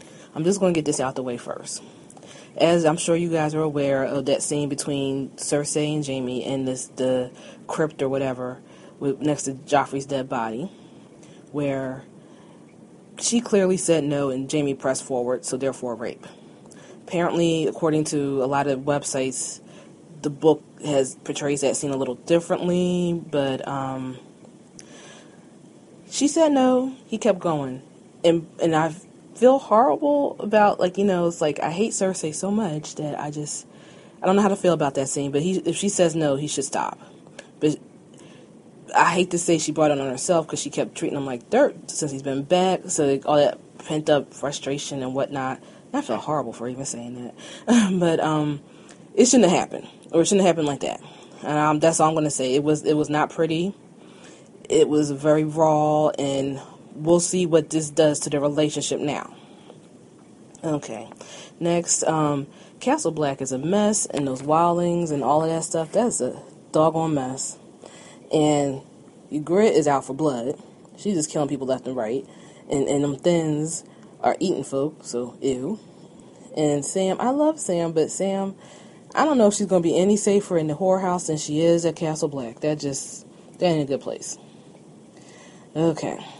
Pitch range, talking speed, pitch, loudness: 140-175 Hz, 180 wpm, 155 Hz, -23 LUFS